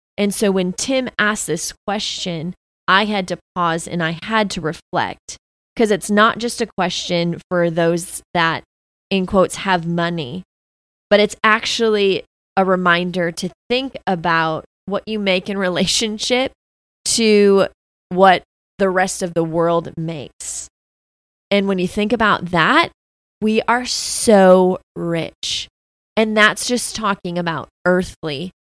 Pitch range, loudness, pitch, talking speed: 170-210 Hz, -18 LUFS, 185 Hz, 140 wpm